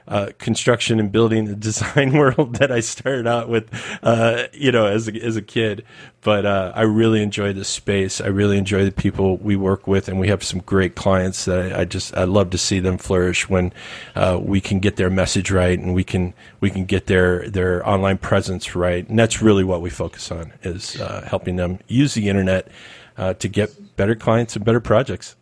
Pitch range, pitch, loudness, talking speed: 95-110 Hz, 100 Hz, -19 LUFS, 215 wpm